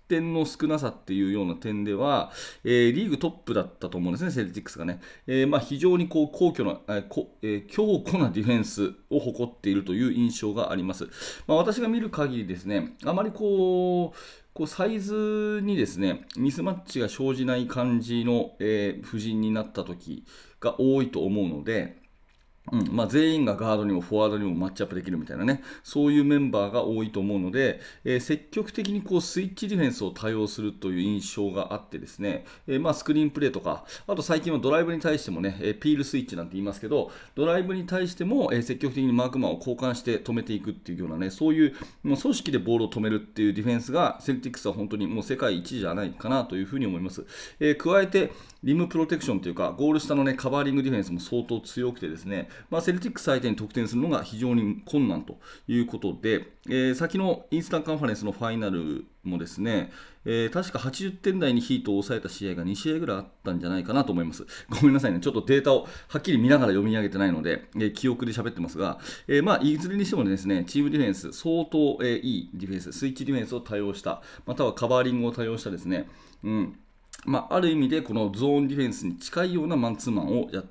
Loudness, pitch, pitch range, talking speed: -27 LUFS, 125 Hz, 105-155 Hz, 475 characters per minute